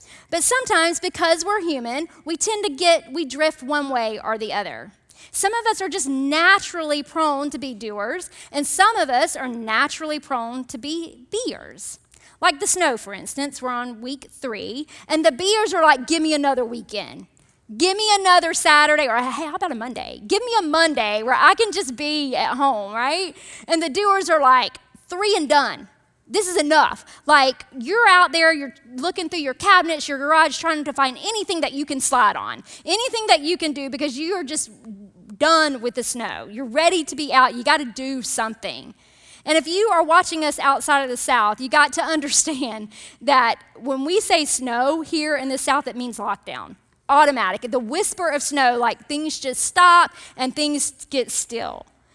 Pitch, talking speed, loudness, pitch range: 295 Hz, 195 wpm, -19 LUFS, 255-340 Hz